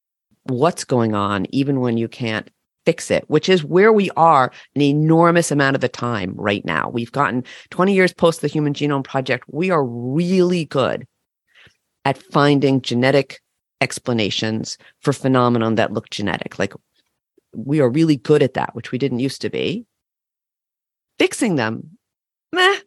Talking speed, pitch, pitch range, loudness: 155 wpm, 140 Hz, 120-165 Hz, -18 LUFS